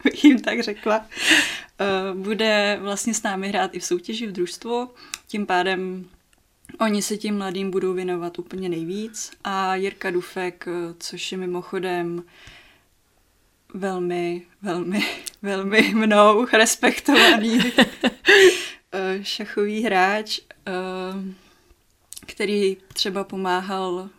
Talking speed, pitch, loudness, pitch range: 100 wpm, 195 Hz, -21 LUFS, 180-220 Hz